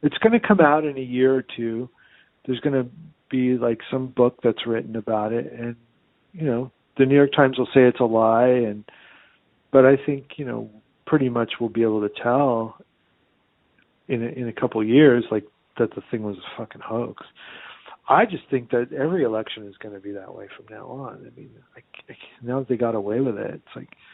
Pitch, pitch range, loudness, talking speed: 125 Hz, 115-135 Hz, -21 LUFS, 220 wpm